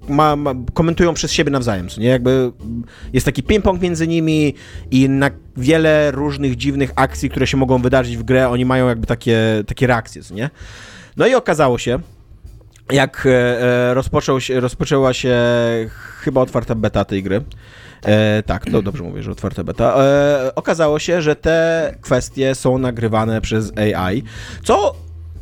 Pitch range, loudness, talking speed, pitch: 110-140 Hz, -16 LUFS, 160 wpm, 130 Hz